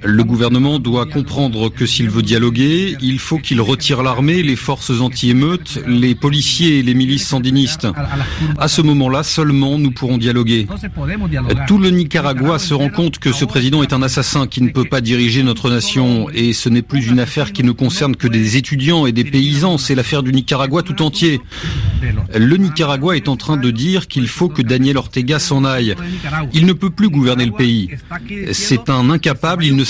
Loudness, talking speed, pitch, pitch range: -14 LUFS, 190 wpm, 135 Hz, 125-150 Hz